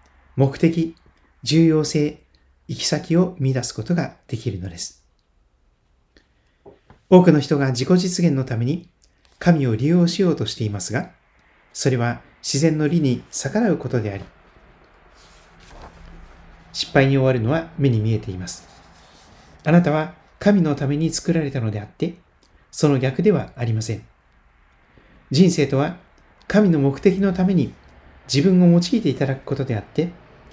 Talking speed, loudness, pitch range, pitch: 265 characters per minute, -20 LUFS, 105-165 Hz, 140 Hz